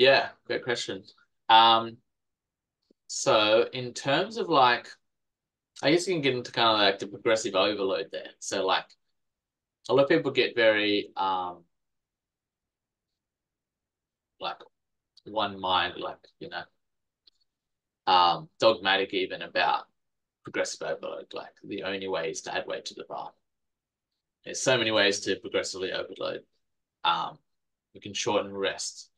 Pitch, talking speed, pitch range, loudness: 105 Hz, 135 wpm, 95-120 Hz, -26 LUFS